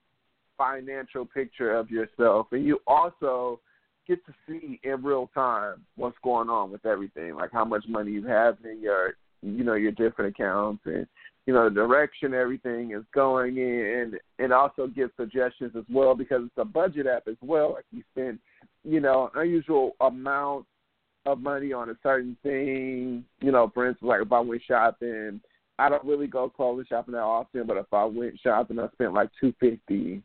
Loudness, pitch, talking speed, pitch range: -27 LUFS, 125 Hz, 190 wpm, 115-140 Hz